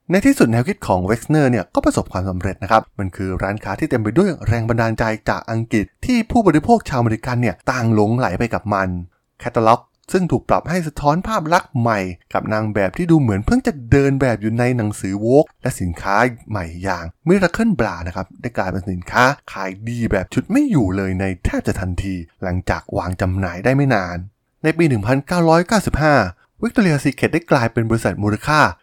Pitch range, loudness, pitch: 95-145 Hz, -18 LUFS, 115 Hz